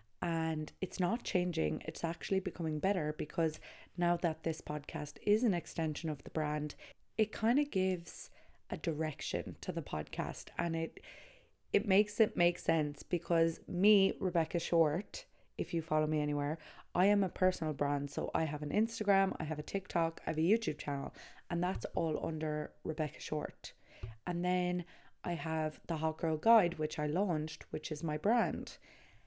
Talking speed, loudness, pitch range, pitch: 170 wpm, -35 LUFS, 155-185 Hz, 165 Hz